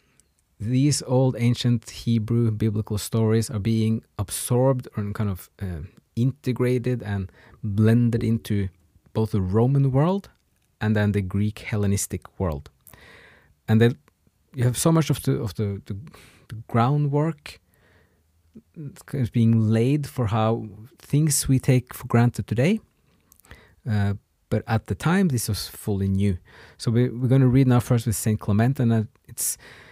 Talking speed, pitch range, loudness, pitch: 150 wpm, 105-125 Hz, -23 LUFS, 115 Hz